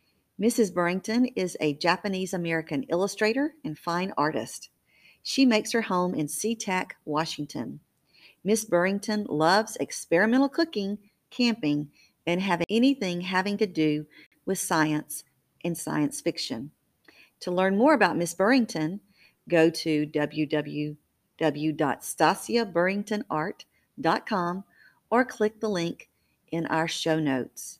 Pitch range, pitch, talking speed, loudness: 155-215 Hz, 180 Hz, 110 wpm, -27 LUFS